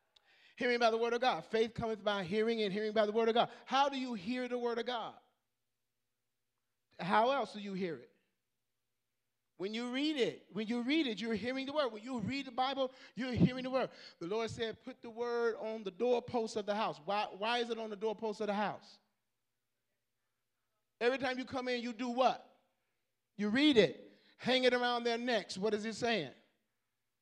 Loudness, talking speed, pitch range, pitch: -35 LUFS, 205 wpm, 175-245 Hz, 225 Hz